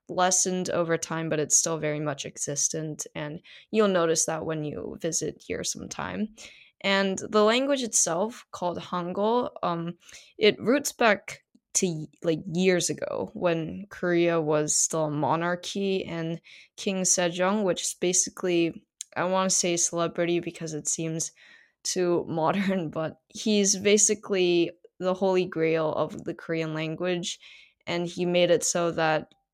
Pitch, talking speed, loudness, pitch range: 175 Hz, 140 wpm, -26 LUFS, 160-190 Hz